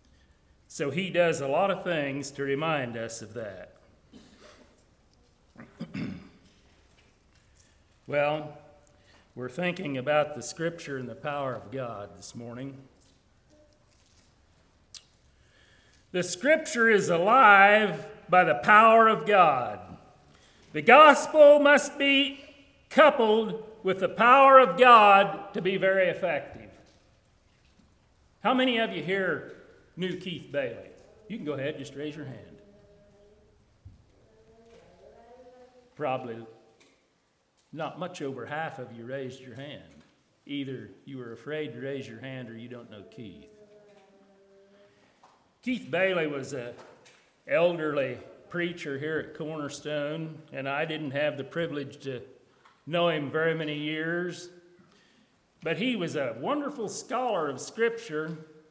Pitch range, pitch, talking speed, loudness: 125-200 Hz, 155 Hz, 120 wpm, -24 LUFS